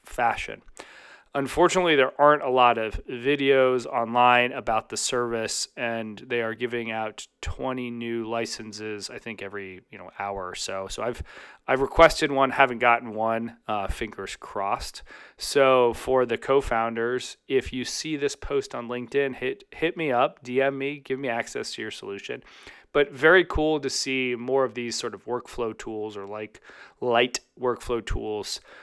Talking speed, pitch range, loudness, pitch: 165 wpm, 115-135 Hz, -25 LUFS, 125 Hz